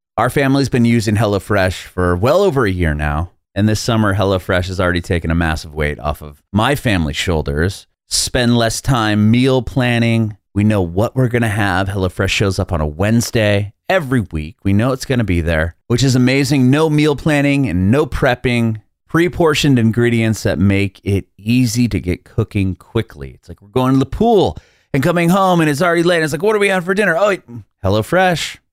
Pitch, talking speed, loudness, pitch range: 110 Hz, 200 wpm, -15 LUFS, 95-130 Hz